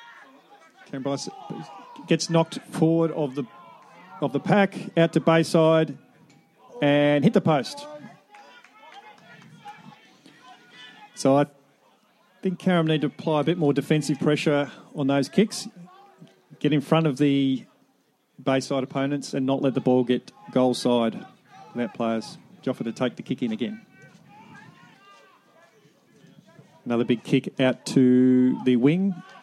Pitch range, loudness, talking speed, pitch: 135-185 Hz, -23 LUFS, 130 wpm, 150 Hz